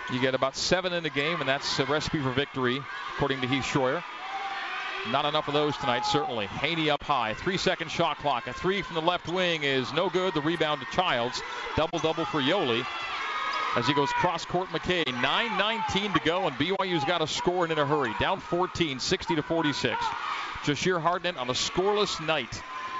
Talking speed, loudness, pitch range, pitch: 195 wpm, -27 LUFS, 140-180 Hz, 160 Hz